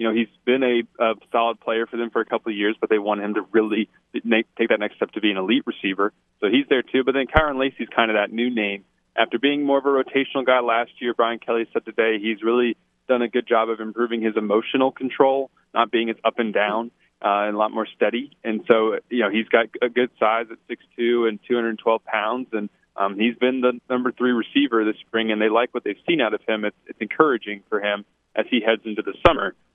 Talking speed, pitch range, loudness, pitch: 255 wpm, 110-125 Hz, -22 LUFS, 115 Hz